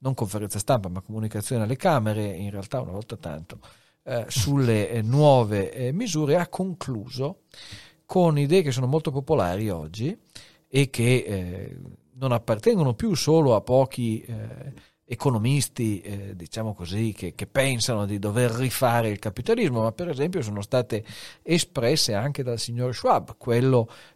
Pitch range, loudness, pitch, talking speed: 105-140 Hz, -24 LUFS, 120 Hz, 150 wpm